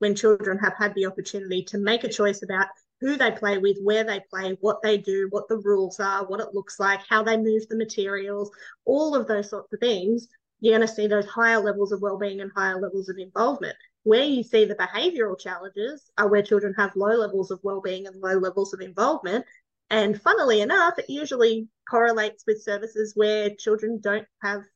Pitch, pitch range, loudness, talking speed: 210 Hz, 200-225 Hz, -24 LUFS, 205 wpm